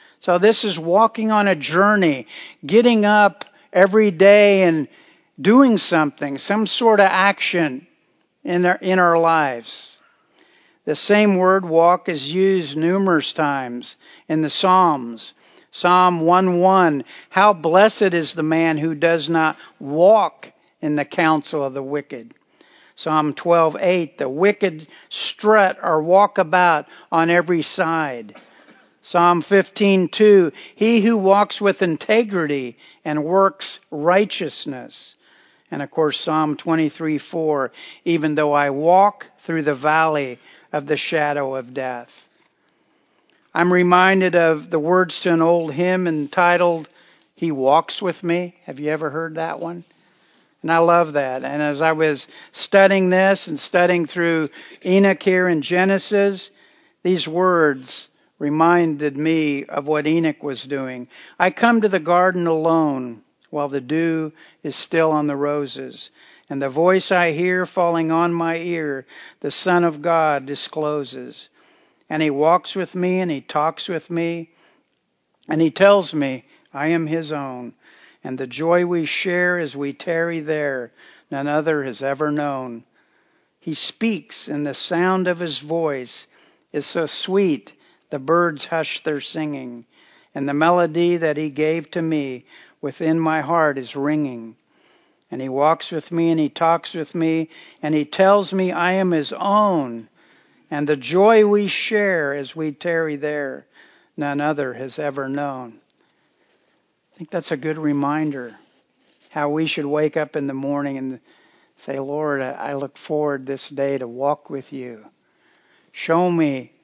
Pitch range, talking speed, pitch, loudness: 145-180 Hz, 145 wpm, 160 Hz, -19 LUFS